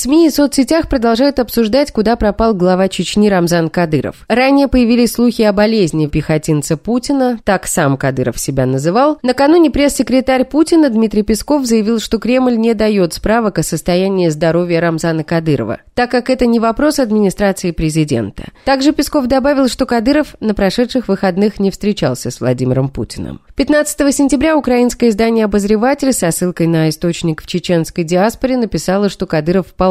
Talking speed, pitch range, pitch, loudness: 150 wpm, 170-260 Hz, 215 Hz, -13 LUFS